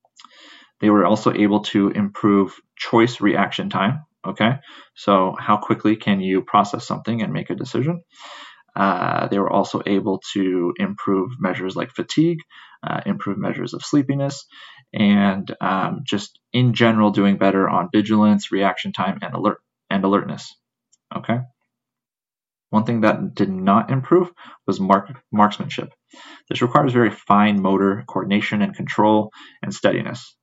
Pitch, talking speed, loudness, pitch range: 105 Hz, 140 wpm, -20 LUFS, 100-120 Hz